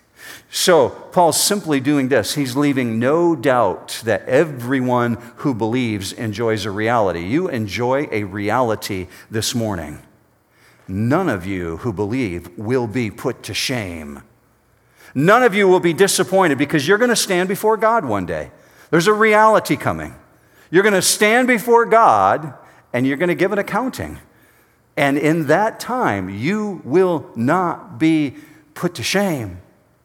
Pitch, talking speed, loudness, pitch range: 140 Hz, 150 wpm, -17 LUFS, 115-185 Hz